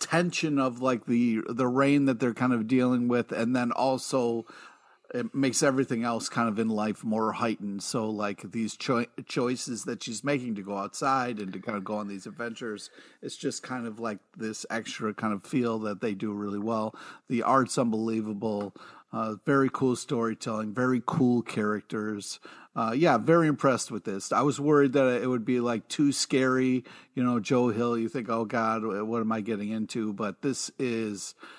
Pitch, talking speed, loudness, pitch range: 115 Hz, 190 wpm, -28 LUFS, 110-130 Hz